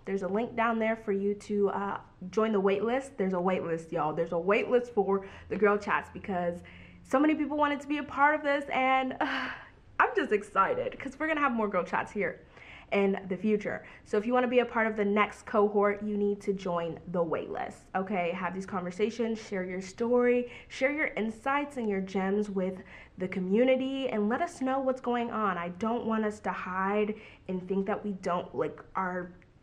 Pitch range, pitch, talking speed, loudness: 190-245 Hz, 210 Hz, 210 wpm, -30 LUFS